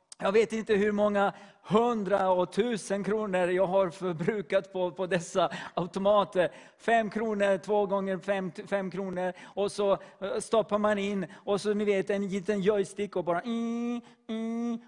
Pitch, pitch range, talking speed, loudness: 200 Hz, 190-215 Hz, 150 wpm, -29 LUFS